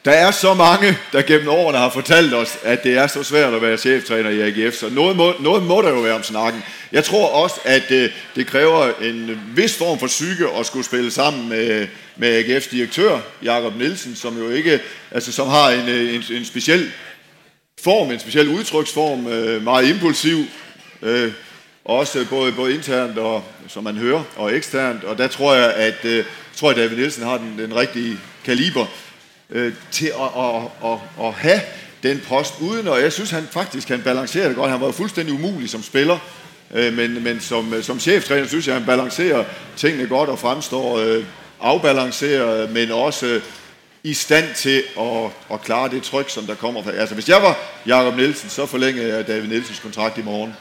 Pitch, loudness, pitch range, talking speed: 125 Hz, -18 LUFS, 115-140 Hz, 185 wpm